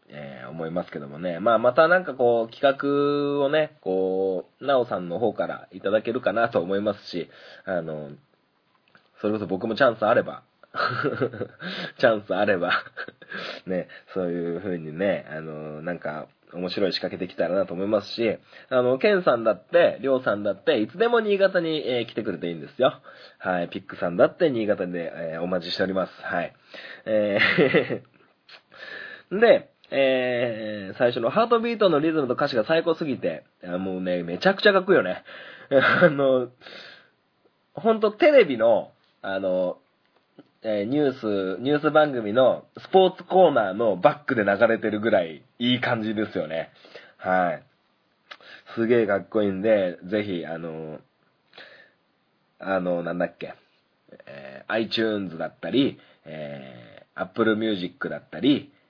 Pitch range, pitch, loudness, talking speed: 90-140 Hz, 110 Hz, -24 LUFS, 320 characters per minute